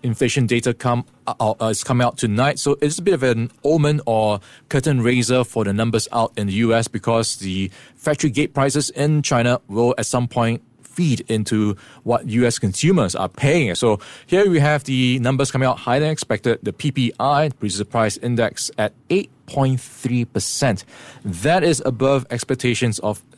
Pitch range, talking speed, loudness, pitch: 115-135 Hz, 180 wpm, -19 LUFS, 125 Hz